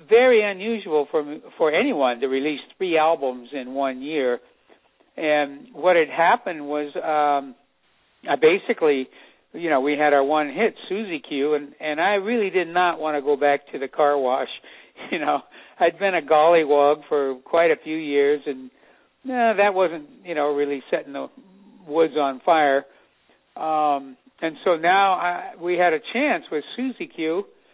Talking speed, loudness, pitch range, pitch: 170 wpm, -22 LUFS, 145-190 Hz, 155 Hz